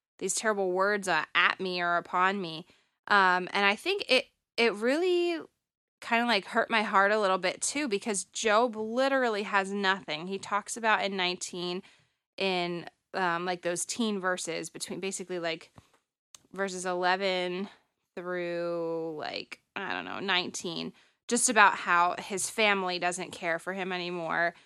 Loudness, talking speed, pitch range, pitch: -29 LUFS, 150 wpm, 180-210 Hz, 190 Hz